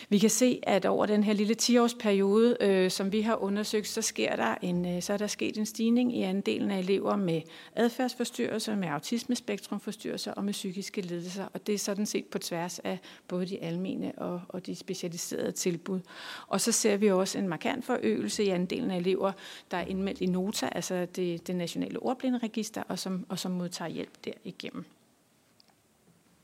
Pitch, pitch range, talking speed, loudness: 200 Hz, 185-220 Hz, 185 wpm, -30 LUFS